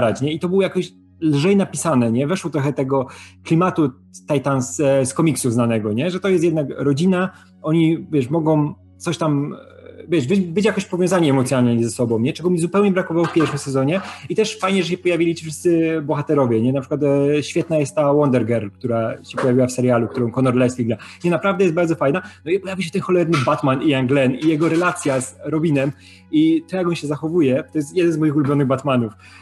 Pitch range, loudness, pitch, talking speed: 130-170 Hz, -19 LUFS, 150 Hz, 205 wpm